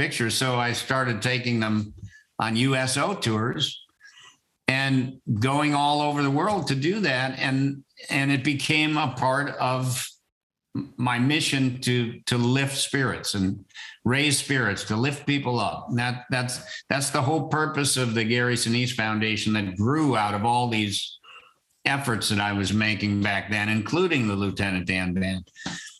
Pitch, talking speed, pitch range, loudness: 125 Hz, 155 wpm, 110-140 Hz, -24 LUFS